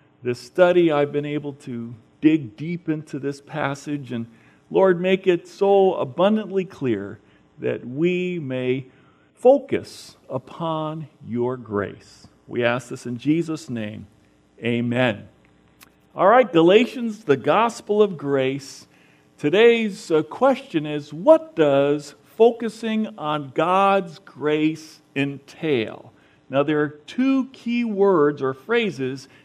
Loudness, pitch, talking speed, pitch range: -21 LUFS, 150 Hz, 115 wpm, 130-195 Hz